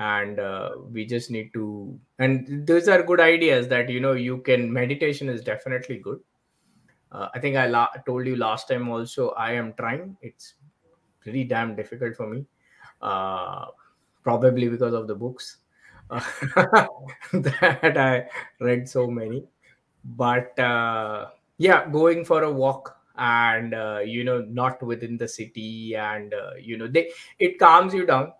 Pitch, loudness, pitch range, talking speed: 125 Hz, -23 LUFS, 115-135 Hz, 160 wpm